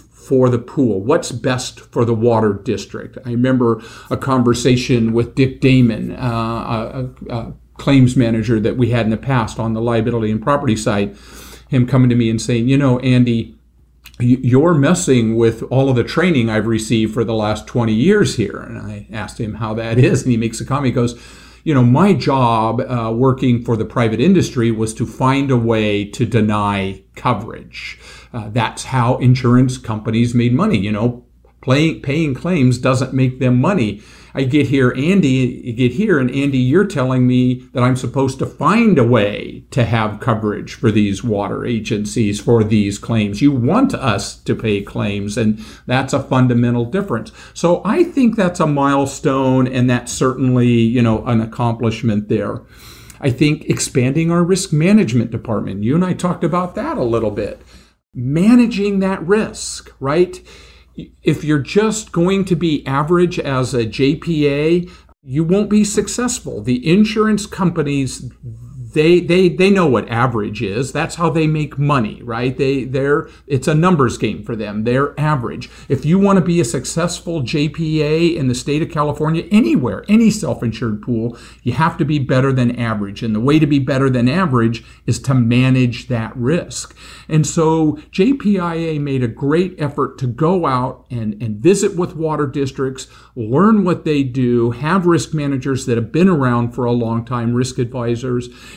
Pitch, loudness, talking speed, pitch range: 130 Hz, -16 LUFS, 175 wpm, 115-155 Hz